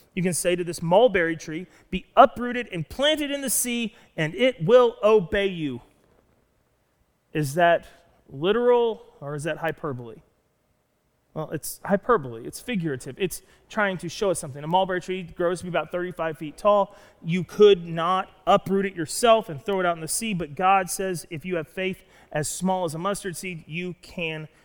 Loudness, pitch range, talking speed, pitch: -24 LUFS, 160-200 Hz, 185 wpm, 180 Hz